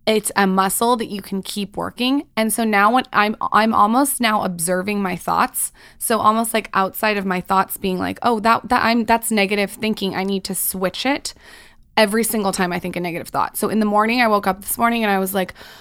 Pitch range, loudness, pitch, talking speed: 190-230 Hz, -19 LUFS, 210 Hz, 230 wpm